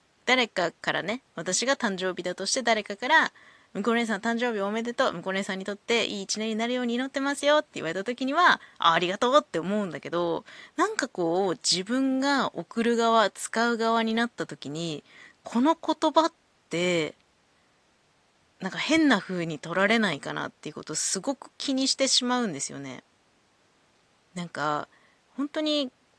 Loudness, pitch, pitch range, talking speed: -26 LUFS, 230 Hz, 185-265 Hz, 340 characters per minute